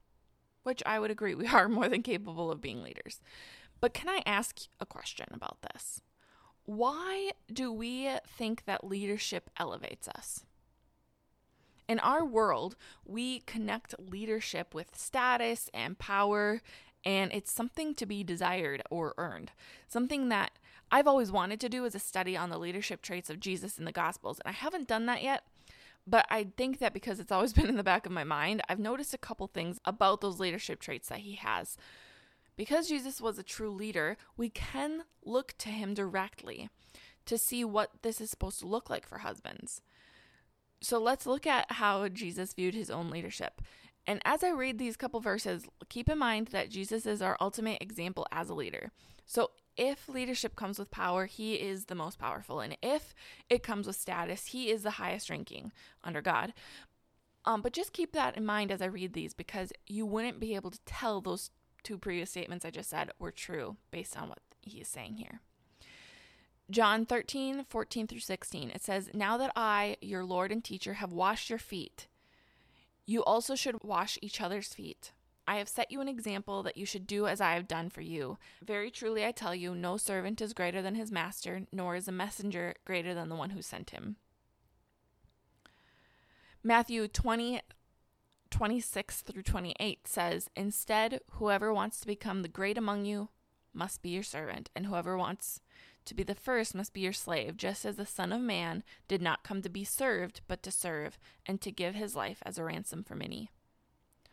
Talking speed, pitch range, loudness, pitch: 185 wpm, 190-230 Hz, -35 LUFS, 205 Hz